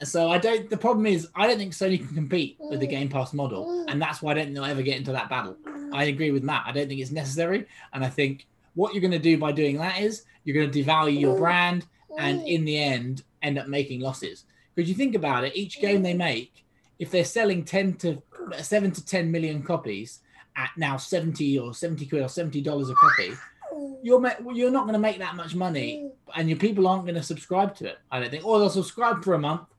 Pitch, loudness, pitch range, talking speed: 165 Hz, -25 LUFS, 145-195 Hz, 240 wpm